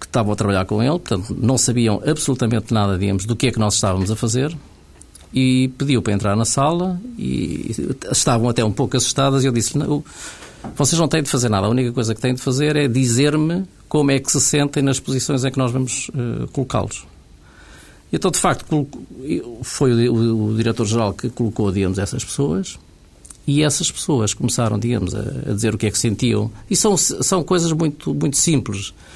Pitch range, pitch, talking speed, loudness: 110-145 Hz, 125 Hz, 200 wpm, -19 LUFS